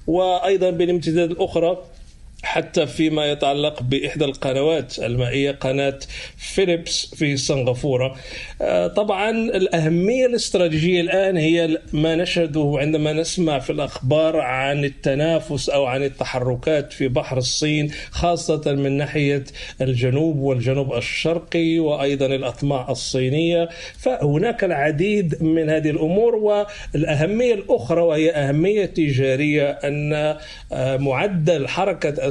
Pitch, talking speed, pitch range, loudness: 155 Hz, 100 wpm, 140-170 Hz, -20 LUFS